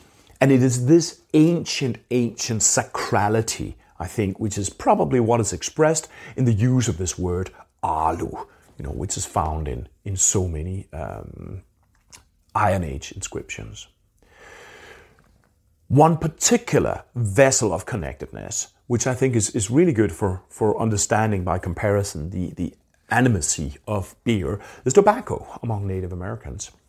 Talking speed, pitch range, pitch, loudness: 140 wpm, 95-125 Hz, 105 Hz, -22 LUFS